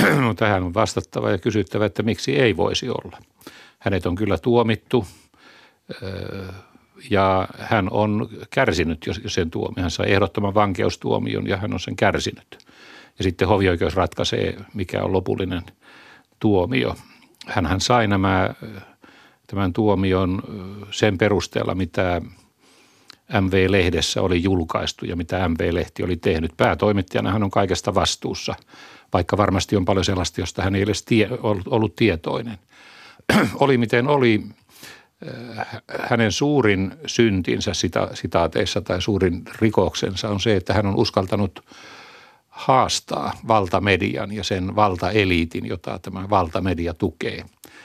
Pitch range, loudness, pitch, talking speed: 95-110 Hz, -21 LUFS, 100 Hz, 120 wpm